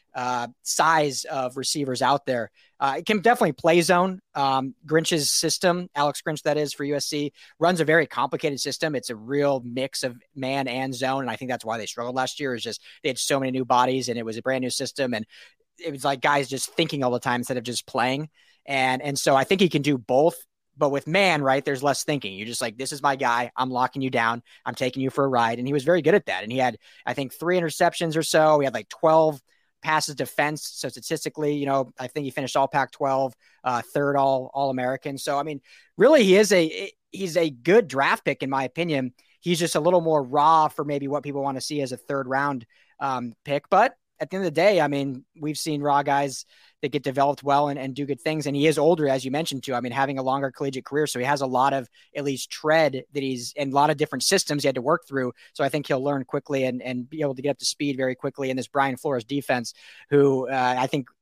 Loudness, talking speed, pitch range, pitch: -24 LUFS, 255 wpm, 130-150 Hz, 140 Hz